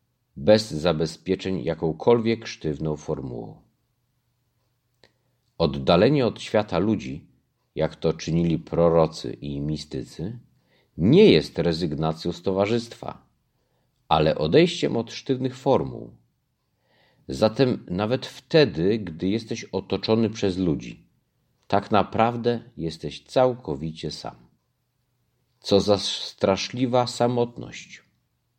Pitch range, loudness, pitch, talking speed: 85-125 Hz, -23 LUFS, 110 Hz, 90 wpm